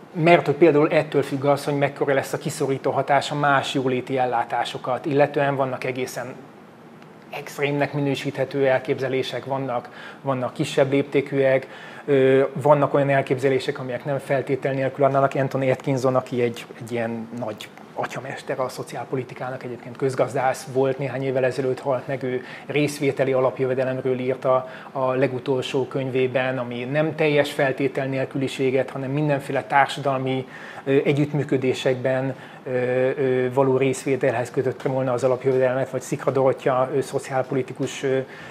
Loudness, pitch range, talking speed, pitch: -23 LUFS, 130-140 Hz, 120 wpm, 135 Hz